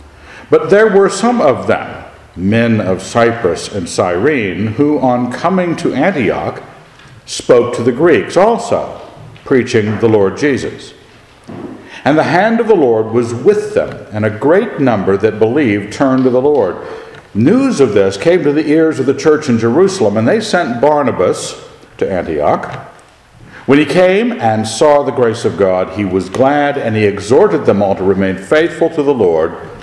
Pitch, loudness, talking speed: 135 Hz, -12 LUFS, 170 wpm